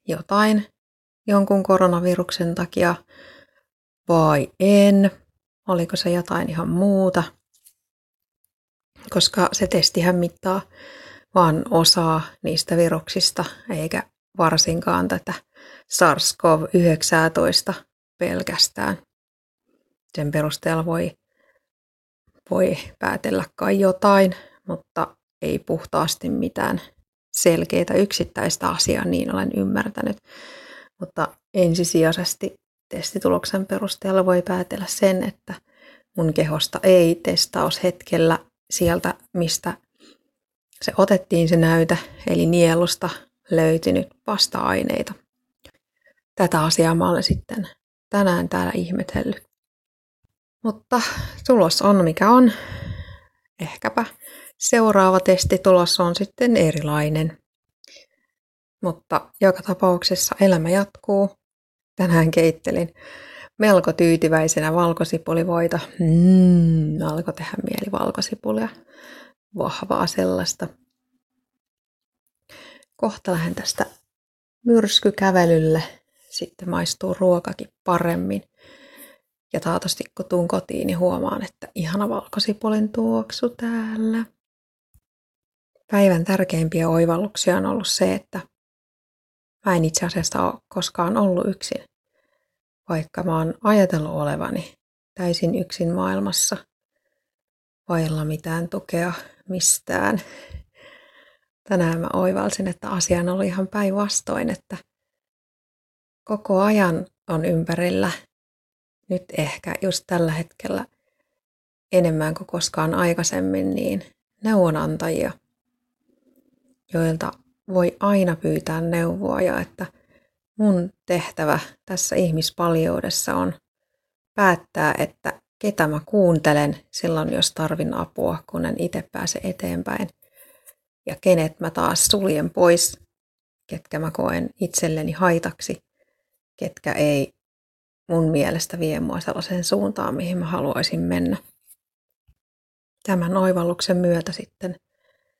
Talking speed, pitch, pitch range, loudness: 95 wpm, 180 Hz, 165-195 Hz, -21 LUFS